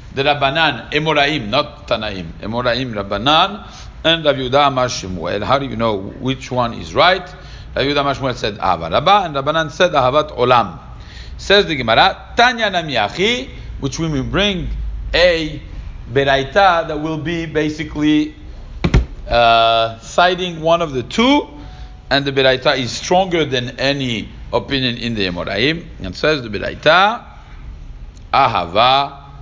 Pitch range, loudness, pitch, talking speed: 120-155 Hz, -16 LUFS, 140 Hz, 135 wpm